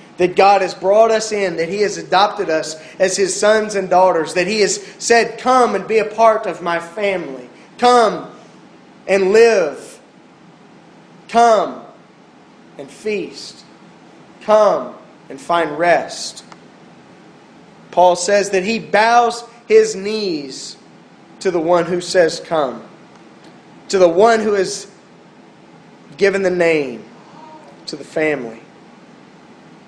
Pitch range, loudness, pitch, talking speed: 180-220 Hz, -15 LUFS, 195 Hz, 125 wpm